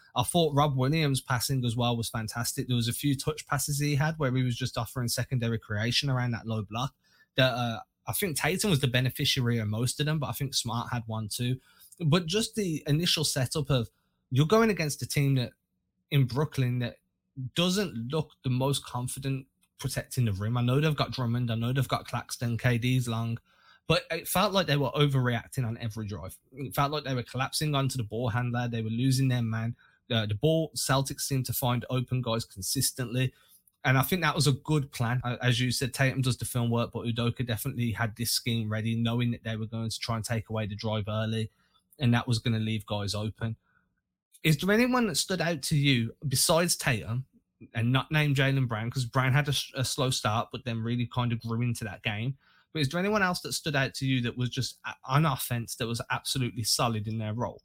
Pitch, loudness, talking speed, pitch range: 125 Hz, -29 LUFS, 225 wpm, 115-140 Hz